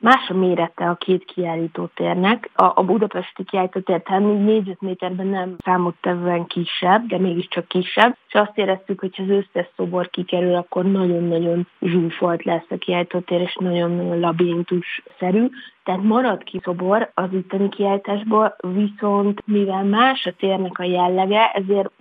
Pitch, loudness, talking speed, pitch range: 185 Hz, -20 LUFS, 140 wpm, 175-200 Hz